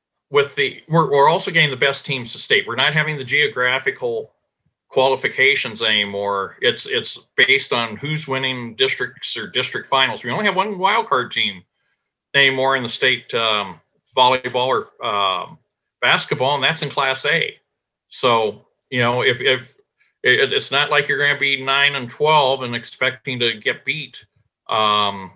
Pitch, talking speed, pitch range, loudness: 135 Hz, 165 wpm, 120-155 Hz, -18 LUFS